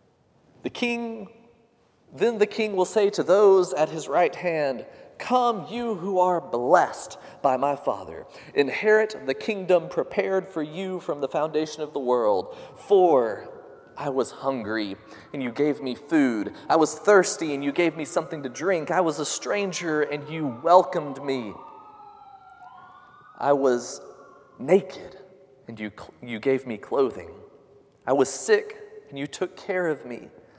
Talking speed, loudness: 155 wpm, -24 LUFS